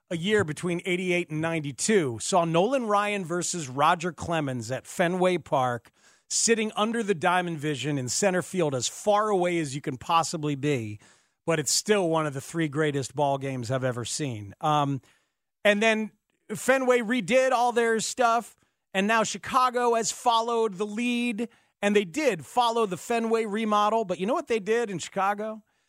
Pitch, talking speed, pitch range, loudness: 185 Hz, 170 wpm, 155-225 Hz, -26 LUFS